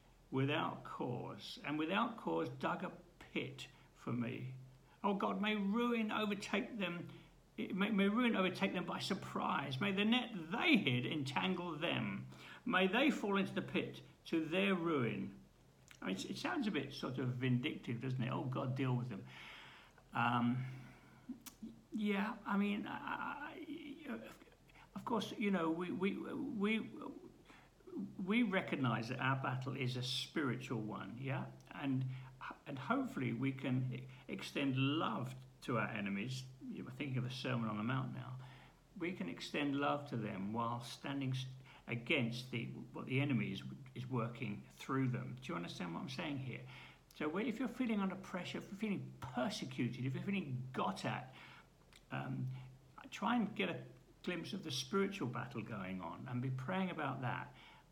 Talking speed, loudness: 160 wpm, -40 LUFS